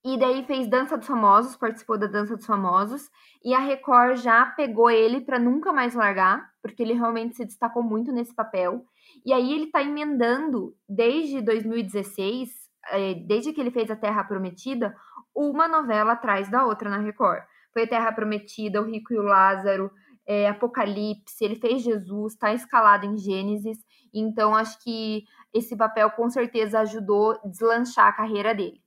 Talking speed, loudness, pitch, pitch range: 170 wpm, -24 LUFS, 225 Hz, 210-250 Hz